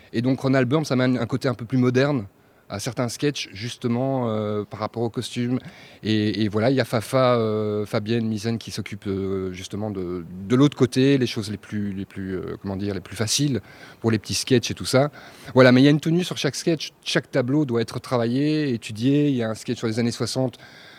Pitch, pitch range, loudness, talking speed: 120 Hz, 105-135 Hz, -23 LUFS, 235 wpm